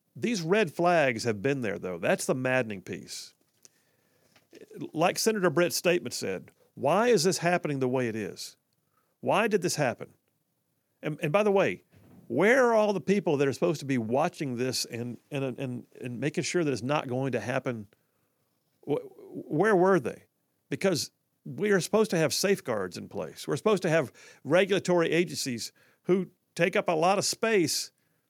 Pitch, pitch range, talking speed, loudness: 160 Hz, 130-190 Hz, 175 wpm, -28 LUFS